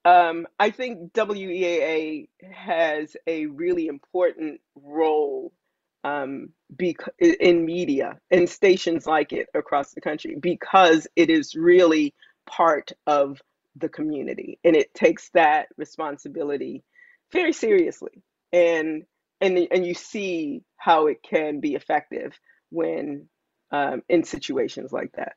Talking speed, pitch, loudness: 120 wpm, 180 Hz, -22 LUFS